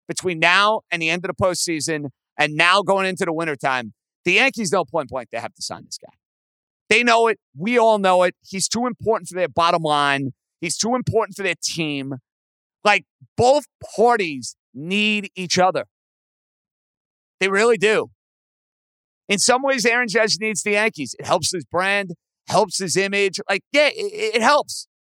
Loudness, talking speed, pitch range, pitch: -19 LUFS, 175 wpm, 165-220 Hz, 190 Hz